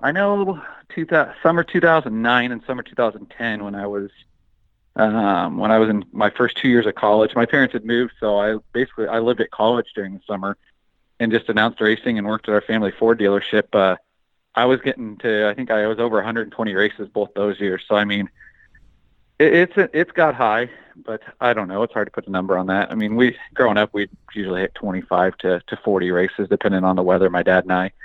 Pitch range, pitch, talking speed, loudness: 100-125 Hz, 110 Hz, 220 wpm, -19 LUFS